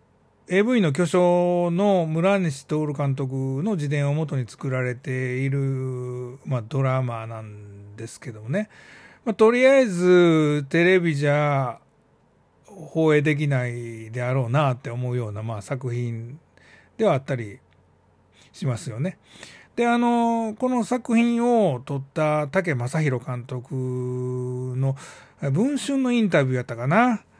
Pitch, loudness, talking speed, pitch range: 140 Hz, -23 LUFS, 250 characters per minute, 125-180 Hz